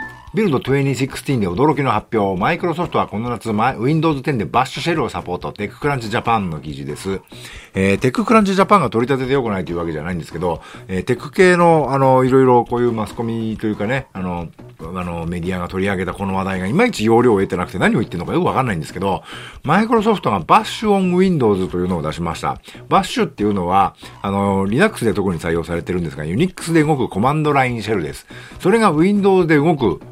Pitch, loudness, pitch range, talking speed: 115 Hz, -17 LUFS, 90-150 Hz, 525 characters per minute